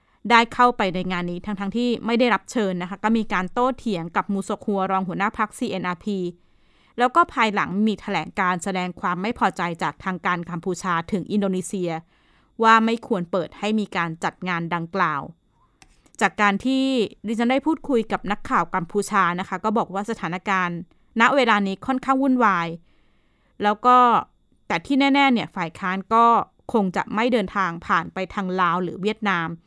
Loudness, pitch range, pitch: -22 LUFS, 180-230 Hz, 200 Hz